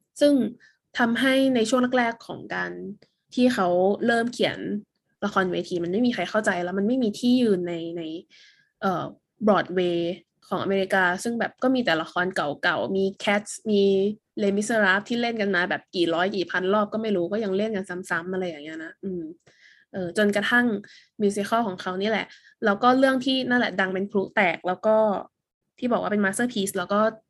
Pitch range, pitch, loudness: 185-230 Hz, 205 Hz, -24 LUFS